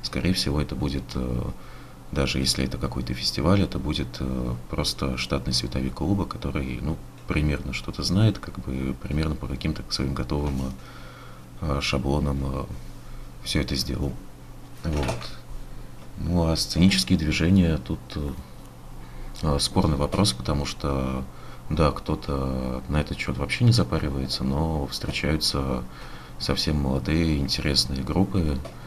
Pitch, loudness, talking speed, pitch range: 70 Hz, -26 LUFS, 115 wpm, 65-80 Hz